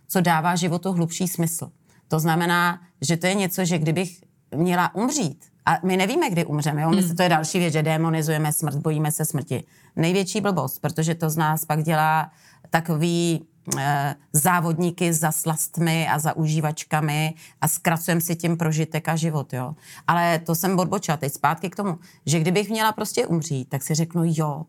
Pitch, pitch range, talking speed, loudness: 165 Hz, 155-175 Hz, 180 wpm, -23 LUFS